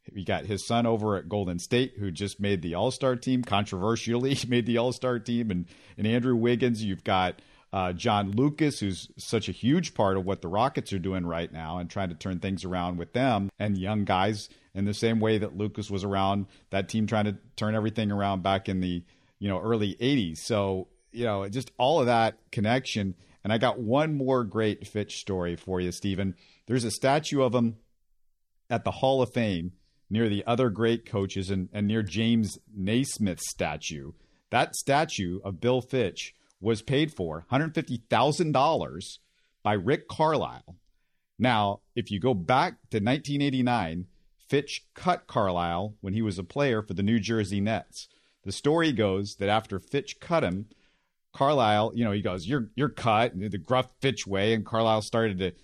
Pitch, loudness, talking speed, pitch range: 105 Hz, -28 LUFS, 185 wpm, 95-120 Hz